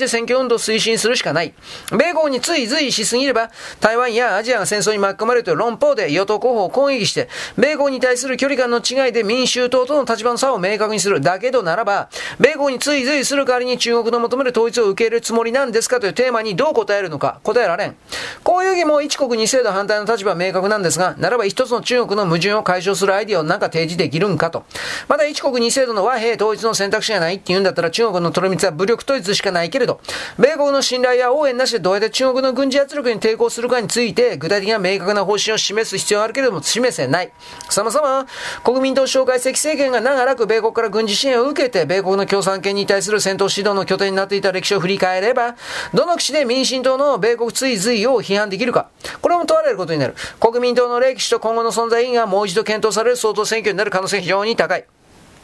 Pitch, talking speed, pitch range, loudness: 230 Hz, 465 characters per minute, 205-255 Hz, -17 LUFS